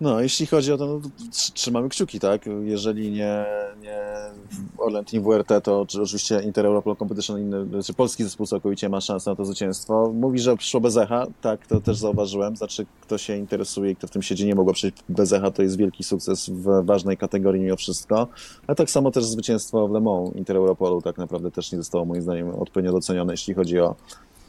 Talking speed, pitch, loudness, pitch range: 200 wpm, 105 Hz, -23 LUFS, 95-110 Hz